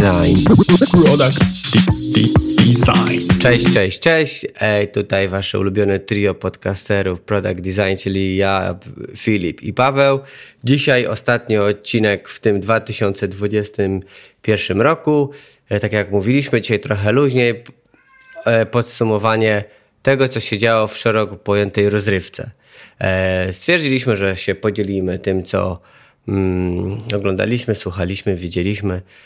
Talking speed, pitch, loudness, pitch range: 105 wpm, 105 Hz, -16 LUFS, 95-115 Hz